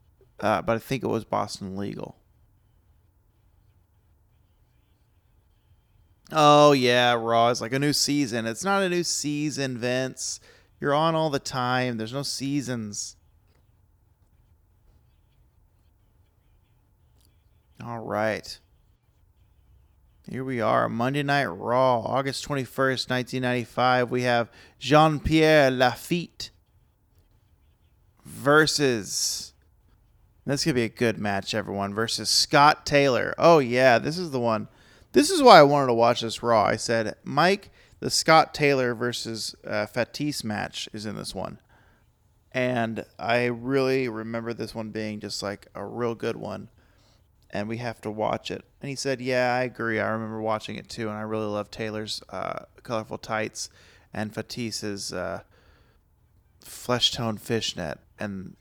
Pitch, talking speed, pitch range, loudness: 115 Hz, 135 wpm, 100-130 Hz, -24 LUFS